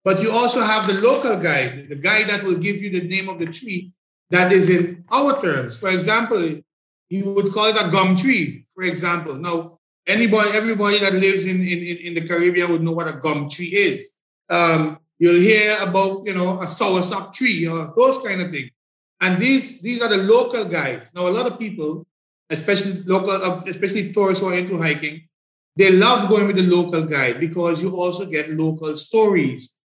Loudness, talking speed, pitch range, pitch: -18 LUFS, 195 wpm, 170-205 Hz, 185 Hz